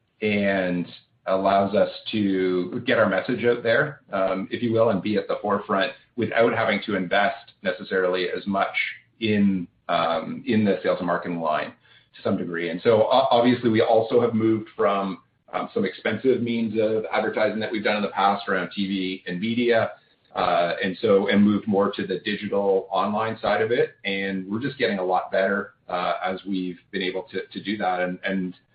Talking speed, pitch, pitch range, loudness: 190 wpm, 100 Hz, 95-110 Hz, -24 LUFS